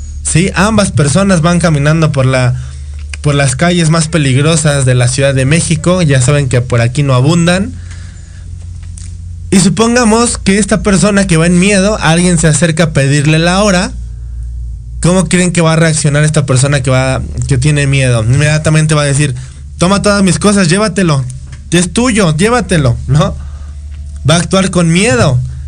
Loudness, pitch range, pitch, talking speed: -9 LUFS, 125-180 Hz, 150 Hz, 165 wpm